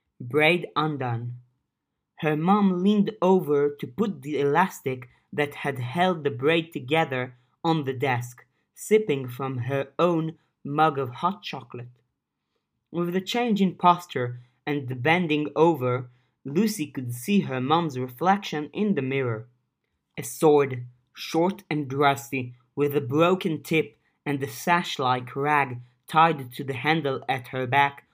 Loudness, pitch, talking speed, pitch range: -25 LUFS, 145 Hz, 140 wpm, 130-165 Hz